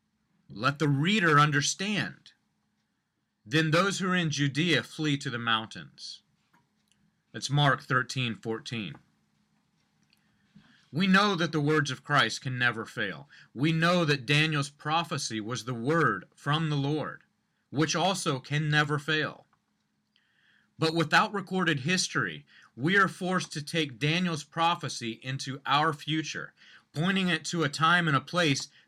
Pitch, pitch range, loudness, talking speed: 150 Hz, 135-165 Hz, -27 LUFS, 135 wpm